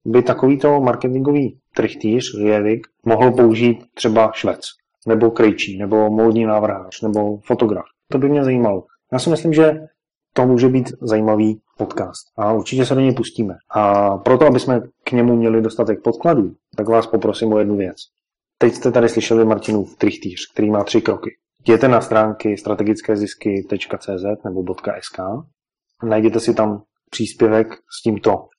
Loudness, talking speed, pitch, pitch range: -17 LUFS, 155 wpm, 115 Hz, 105-125 Hz